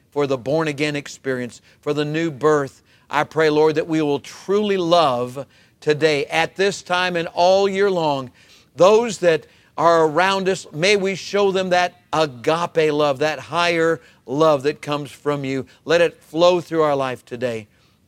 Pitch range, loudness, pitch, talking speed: 140-175 Hz, -19 LUFS, 155 Hz, 170 wpm